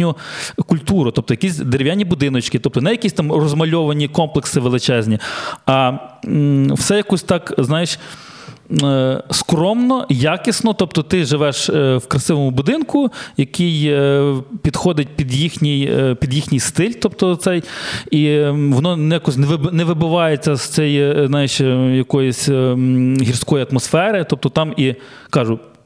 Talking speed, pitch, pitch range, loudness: 115 wpm, 150 Hz, 135-170 Hz, -16 LUFS